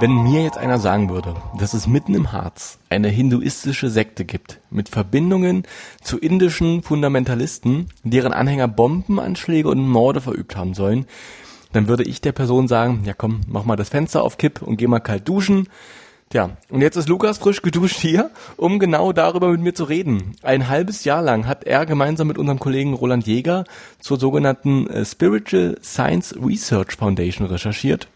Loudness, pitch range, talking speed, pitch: -19 LUFS, 110-165 Hz, 175 wpm, 130 Hz